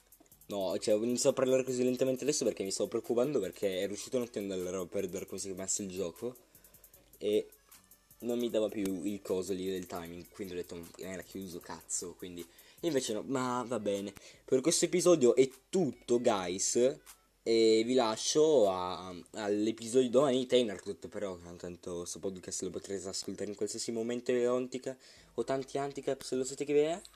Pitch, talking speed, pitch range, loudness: 115 Hz, 190 wpm, 95-130 Hz, -33 LUFS